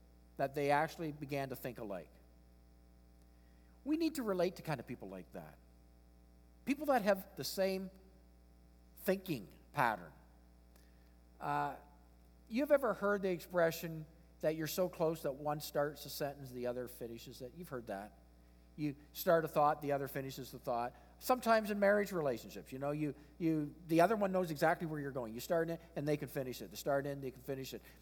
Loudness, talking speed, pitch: -38 LUFS, 185 wpm, 140 Hz